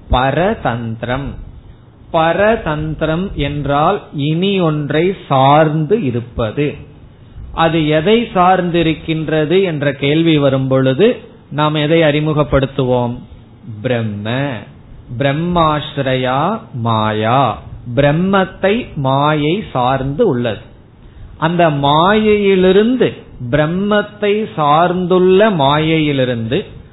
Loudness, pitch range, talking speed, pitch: -14 LUFS, 125-175 Hz, 65 wpm, 150 Hz